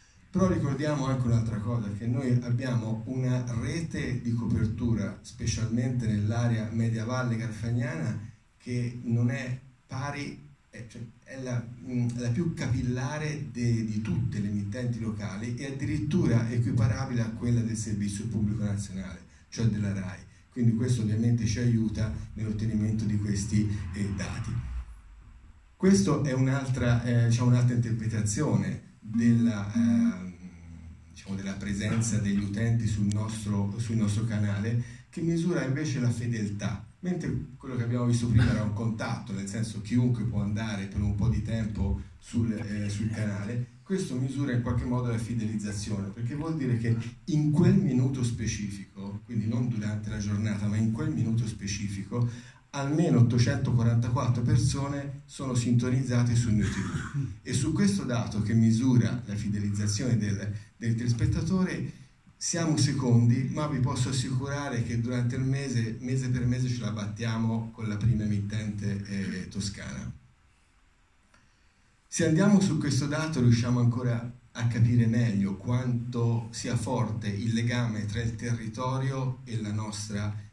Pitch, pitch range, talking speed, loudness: 115 Hz, 105-125 Hz, 140 wpm, -29 LUFS